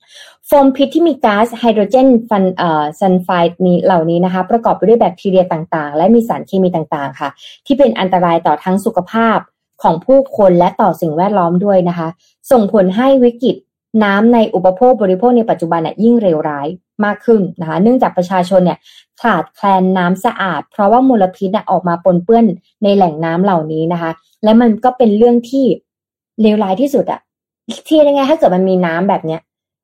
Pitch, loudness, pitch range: 190 Hz, -12 LUFS, 175-235 Hz